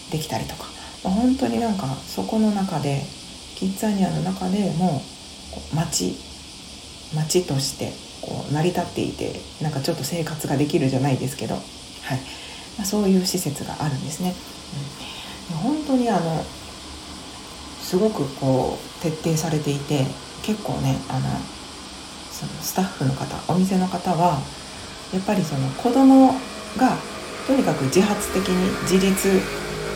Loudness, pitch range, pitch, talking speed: -23 LUFS, 135-195 Hz, 170 Hz, 280 characters per minute